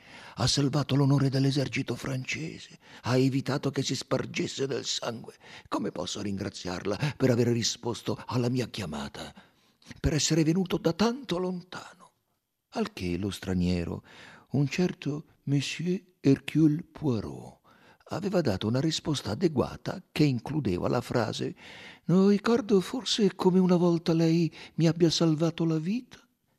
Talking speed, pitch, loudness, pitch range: 130 wpm, 140 Hz, -28 LUFS, 125-170 Hz